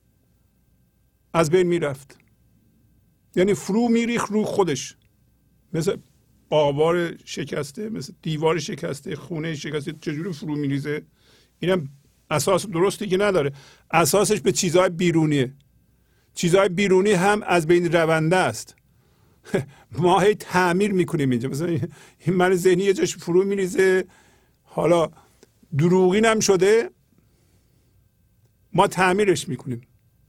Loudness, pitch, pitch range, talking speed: -21 LUFS, 175 Hz, 145-190 Hz, 110 wpm